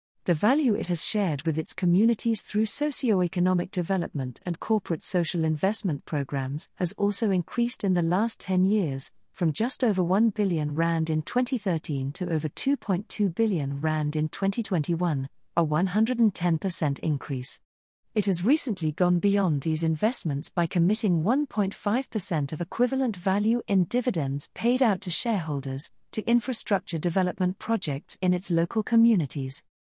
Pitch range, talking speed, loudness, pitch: 160-220 Hz, 140 wpm, -26 LUFS, 180 Hz